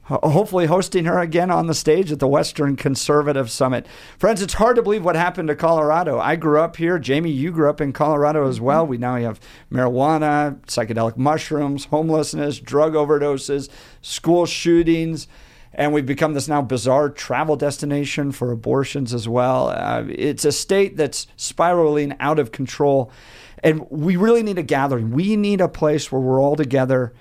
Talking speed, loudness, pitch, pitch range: 175 wpm, -19 LUFS, 150 Hz, 135-160 Hz